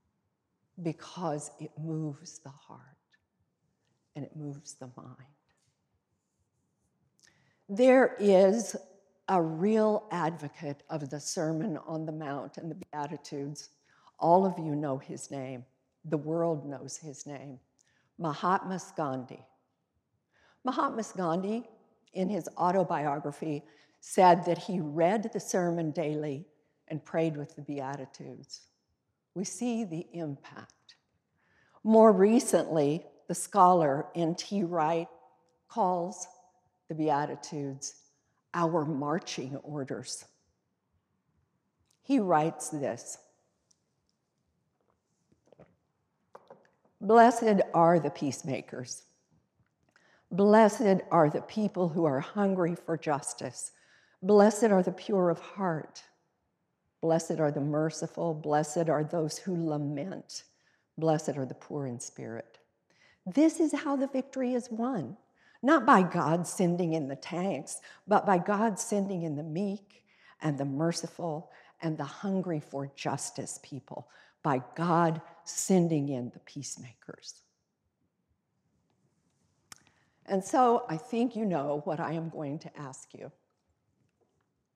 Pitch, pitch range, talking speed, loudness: 165 Hz, 145-190 Hz, 110 wpm, -29 LUFS